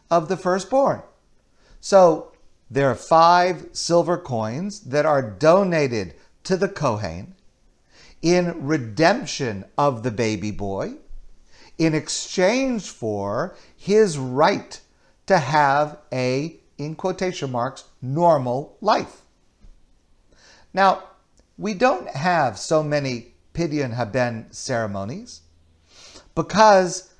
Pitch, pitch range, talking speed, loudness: 150 Hz, 120-180 Hz, 95 wpm, -21 LUFS